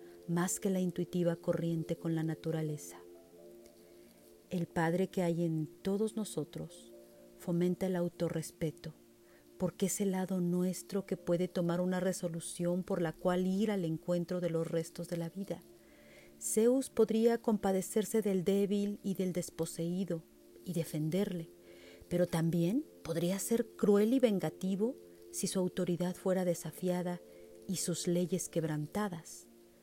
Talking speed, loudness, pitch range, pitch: 135 wpm, -35 LUFS, 165-190 Hz, 175 Hz